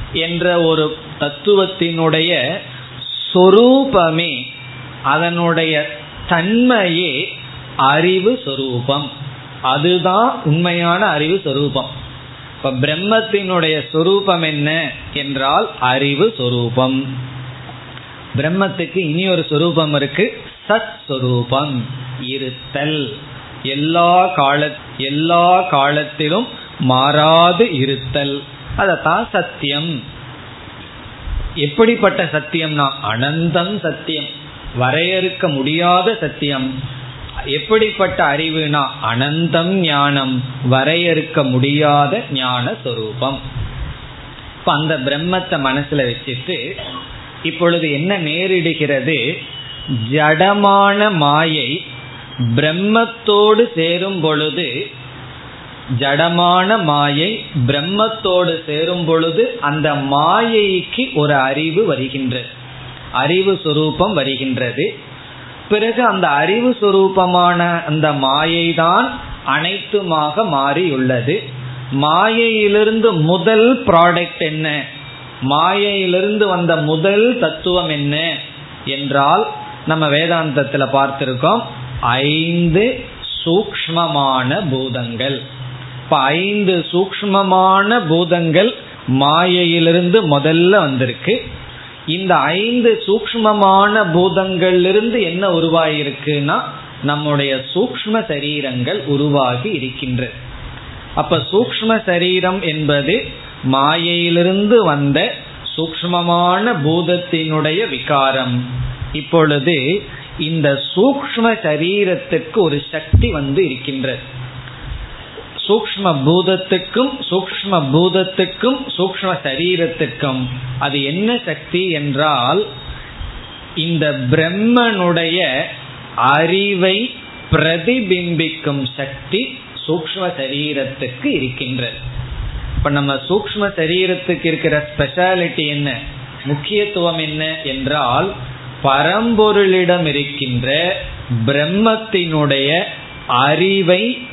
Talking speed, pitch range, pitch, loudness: 65 wpm, 135-180 Hz, 155 Hz, -15 LUFS